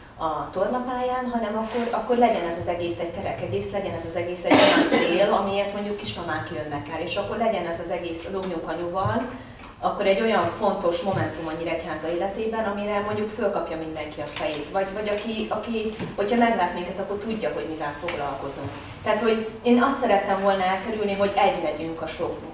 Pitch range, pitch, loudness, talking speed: 165-215 Hz, 195 Hz, -25 LUFS, 185 wpm